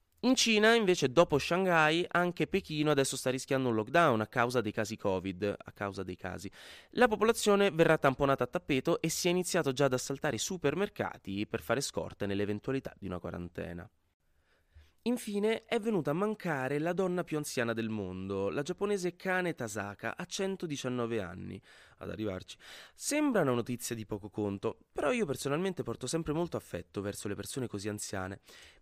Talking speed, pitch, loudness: 170 wpm, 130 Hz, -32 LUFS